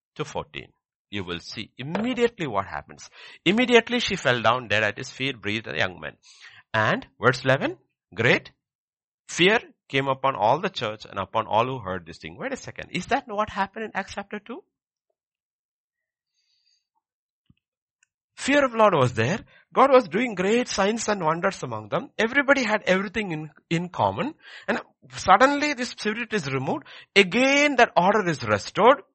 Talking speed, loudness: 160 wpm, -23 LUFS